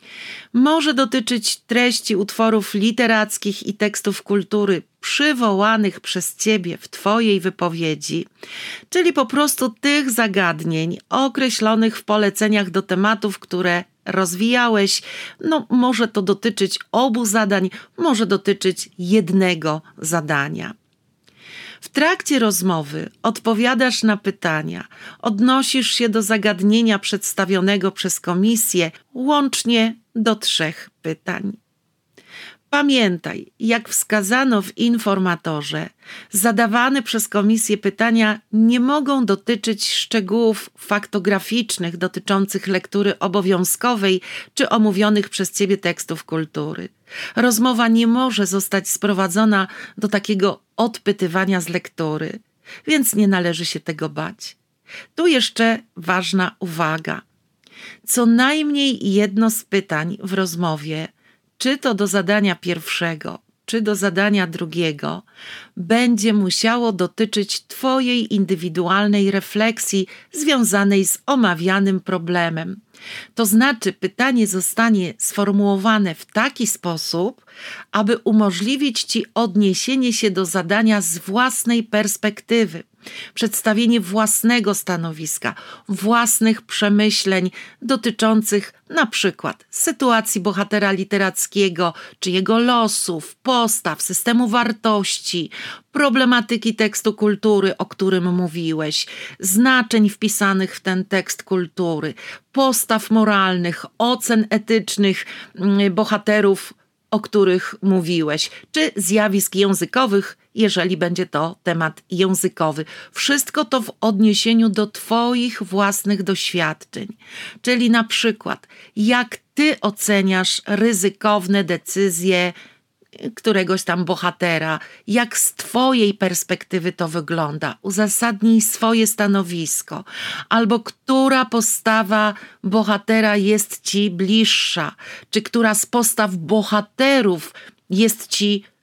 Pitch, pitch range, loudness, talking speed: 210 Hz, 190-230 Hz, -18 LUFS, 100 wpm